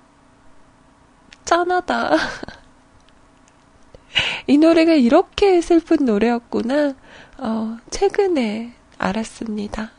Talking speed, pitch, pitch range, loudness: 150 characters per minute, 290 Hz, 230-345 Hz, -18 LUFS